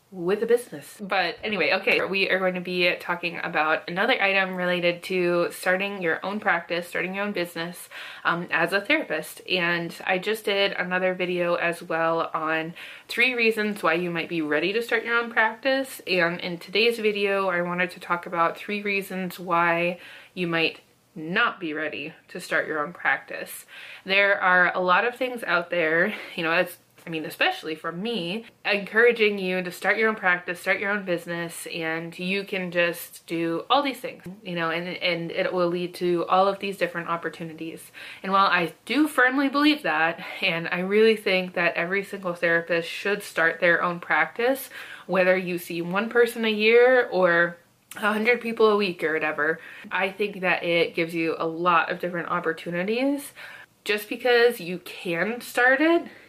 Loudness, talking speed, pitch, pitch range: -24 LUFS, 180 wpm, 180 Hz, 170-205 Hz